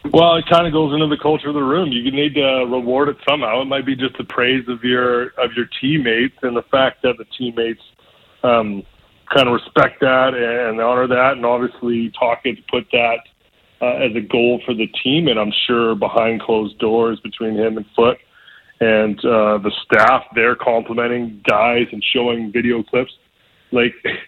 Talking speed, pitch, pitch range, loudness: 190 wpm, 120 Hz, 115-130 Hz, -17 LUFS